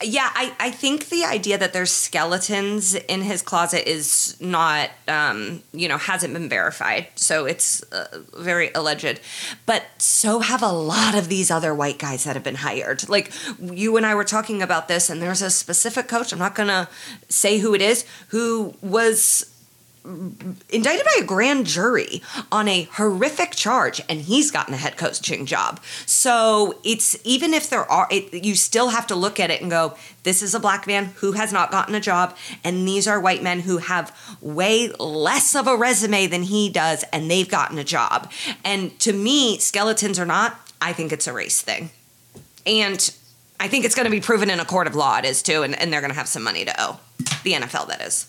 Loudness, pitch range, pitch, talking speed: -20 LUFS, 175-225 Hz, 200 Hz, 210 wpm